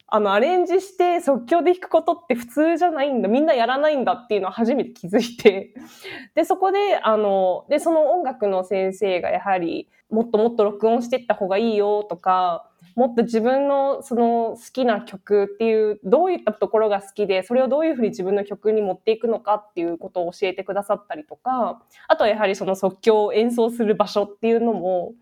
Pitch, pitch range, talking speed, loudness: 220 Hz, 200-265 Hz, 420 characters per minute, -21 LUFS